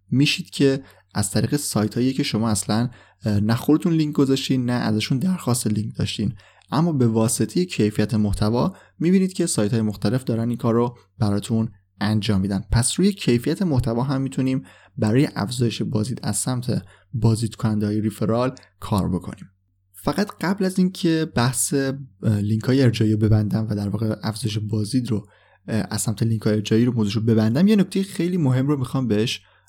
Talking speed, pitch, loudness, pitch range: 165 wpm, 115 Hz, -22 LUFS, 105-135 Hz